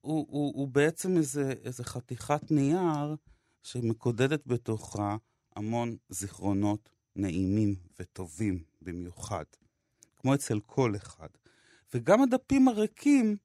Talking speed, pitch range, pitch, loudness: 100 wpm, 105-145 Hz, 120 Hz, -30 LUFS